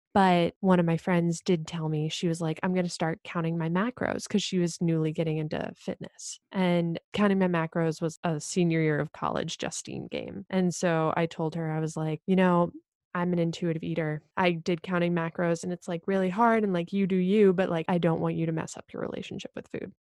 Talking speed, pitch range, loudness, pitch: 230 wpm, 165-185 Hz, -28 LUFS, 170 Hz